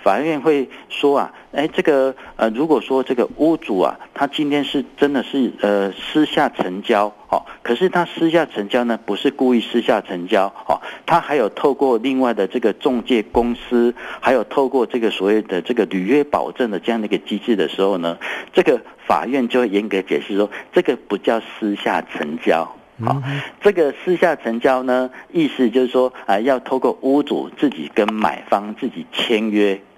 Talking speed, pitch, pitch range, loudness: 275 characters per minute, 125 Hz, 110-140 Hz, -19 LUFS